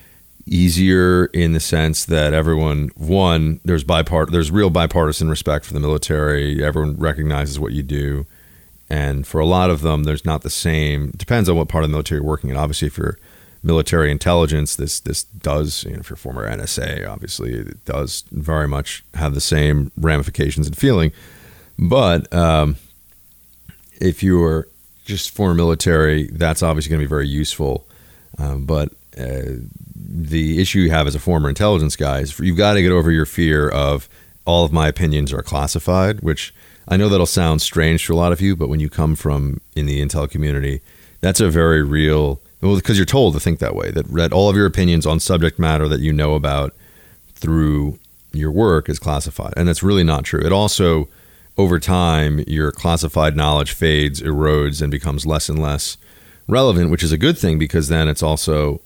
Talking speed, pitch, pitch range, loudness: 190 wpm, 80 Hz, 75-85 Hz, -17 LUFS